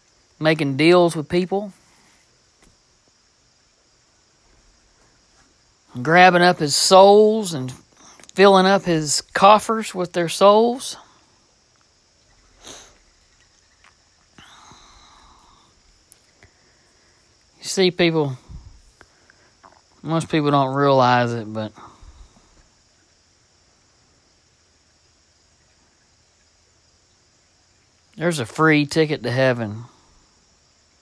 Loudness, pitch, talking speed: -17 LUFS, 130 Hz, 60 wpm